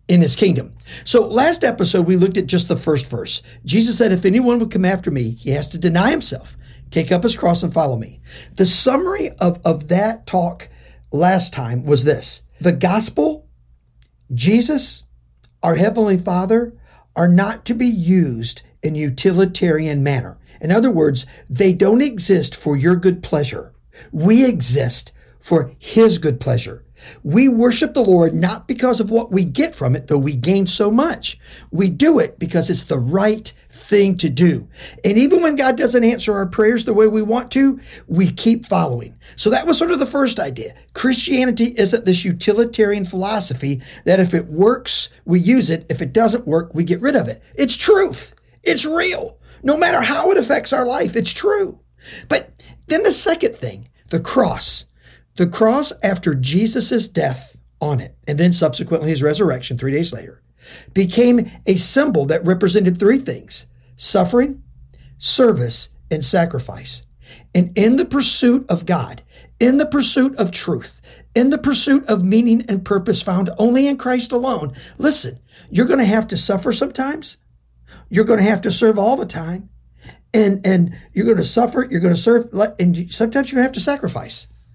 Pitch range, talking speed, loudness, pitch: 160-235 Hz, 175 wpm, -16 LUFS, 190 Hz